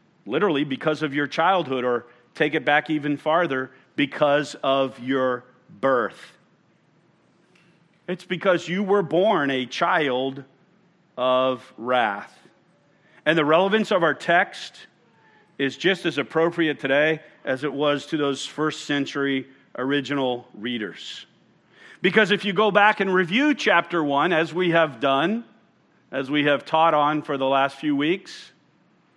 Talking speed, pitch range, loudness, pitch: 140 wpm, 135-180 Hz, -22 LUFS, 150 Hz